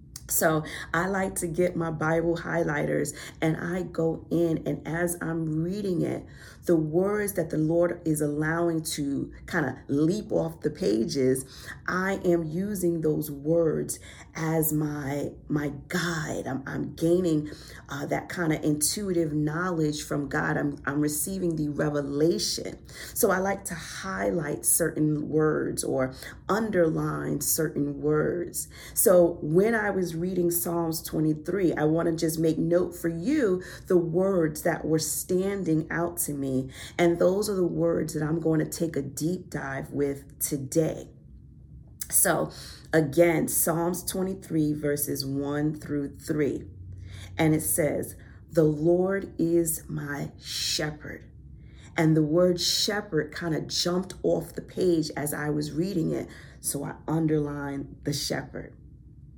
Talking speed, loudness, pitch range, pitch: 140 wpm, -27 LUFS, 150-175 Hz, 160 Hz